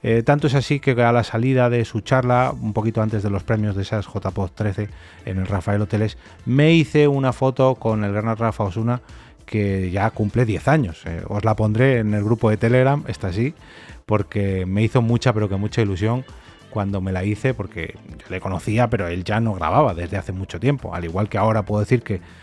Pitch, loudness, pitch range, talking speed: 110 Hz, -20 LUFS, 100-120 Hz, 220 wpm